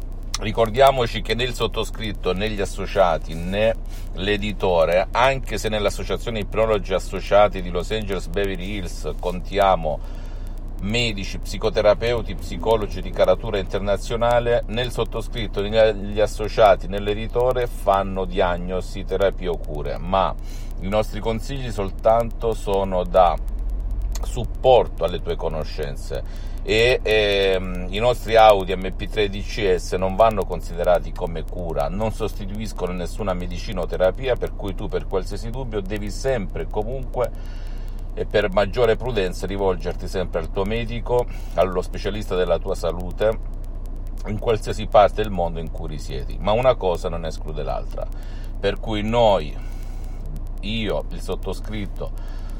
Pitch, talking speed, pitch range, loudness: 100 Hz, 120 wpm, 90-110 Hz, -22 LUFS